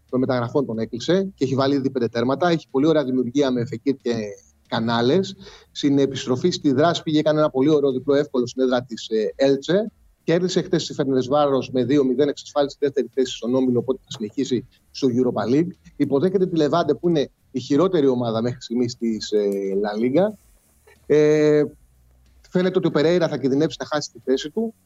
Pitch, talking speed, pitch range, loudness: 135 Hz, 185 wpm, 120-150 Hz, -21 LUFS